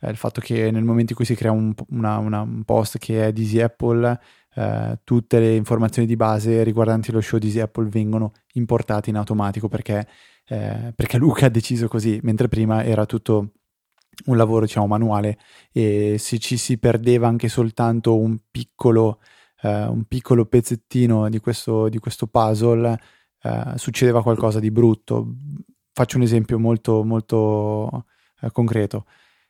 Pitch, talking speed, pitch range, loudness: 115 Hz, 165 wpm, 110-120 Hz, -20 LUFS